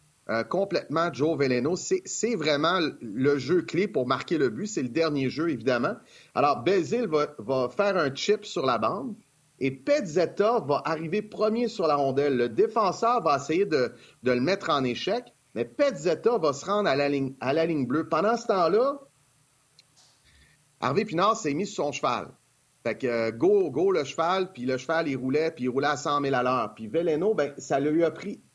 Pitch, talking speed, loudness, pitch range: 160 Hz, 200 wpm, -26 LUFS, 135-215 Hz